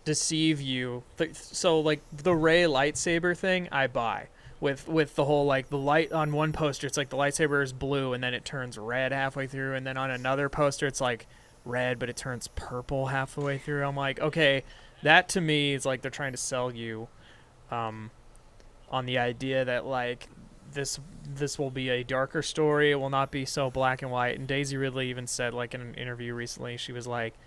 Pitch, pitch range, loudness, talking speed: 135 Hz, 125-145 Hz, -29 LUFS, 205 wpm